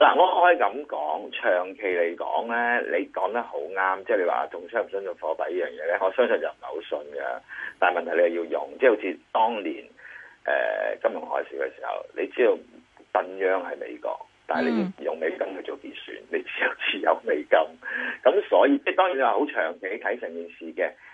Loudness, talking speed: -25 LUFS, 300 characters per minute